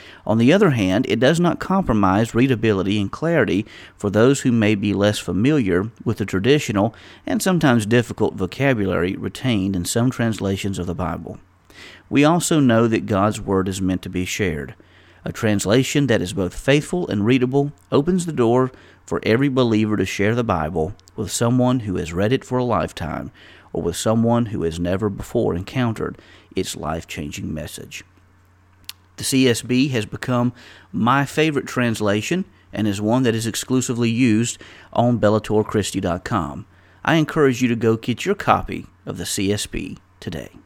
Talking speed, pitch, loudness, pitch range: 160 wpm, 110 Hz, -20 LUFS, 95-125 Hz